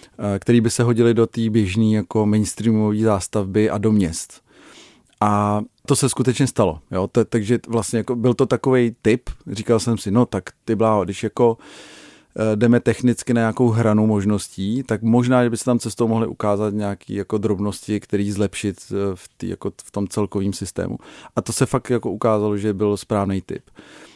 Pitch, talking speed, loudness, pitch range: 110 Hz, 180 wpm, -20 LUFS, 105-120 Hz